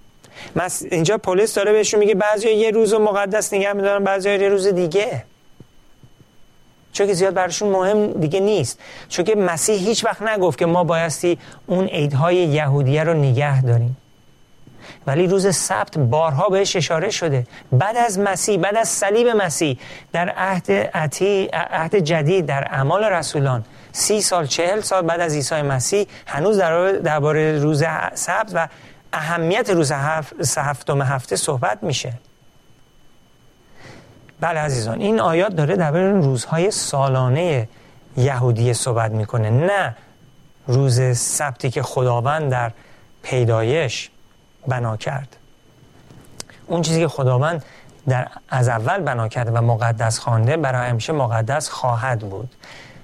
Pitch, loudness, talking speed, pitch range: 155 Hz, -19 LUFS, 130 wpm, 130-190 Hz